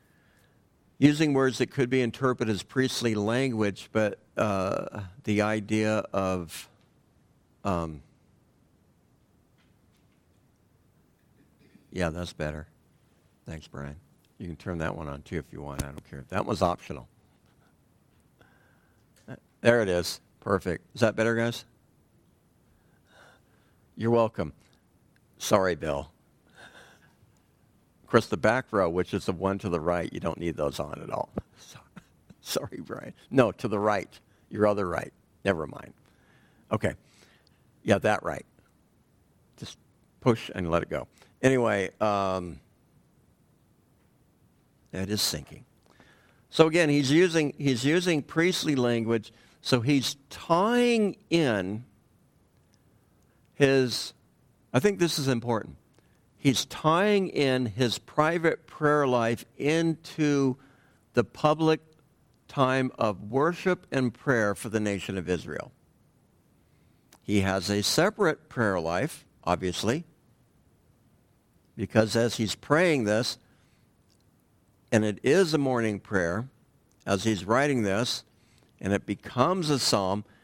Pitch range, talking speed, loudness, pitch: 100-135 Hz, 115 wpm, -27 LUFS, 115 Hz